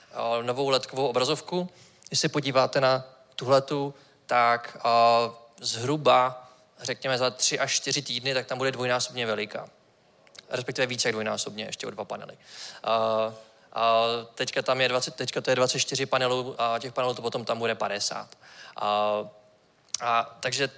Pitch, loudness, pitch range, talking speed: 125 Hz, -26 LUFS, 115-130 Hz, 140 wpm